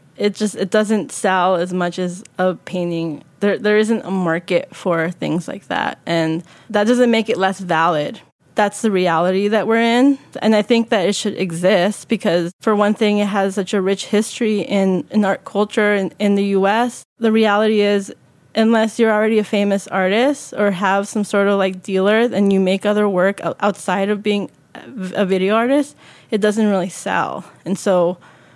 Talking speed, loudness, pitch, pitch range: 190 wpm, -17 LUFS, 200 Hz, 185-215 Hz